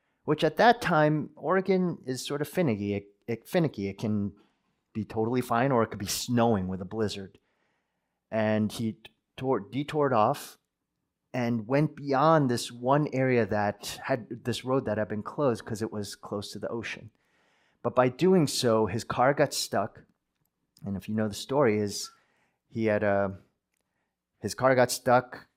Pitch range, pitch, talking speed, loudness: 105-135 Hz, 115 Hz, 170 wpm, -28 LUFS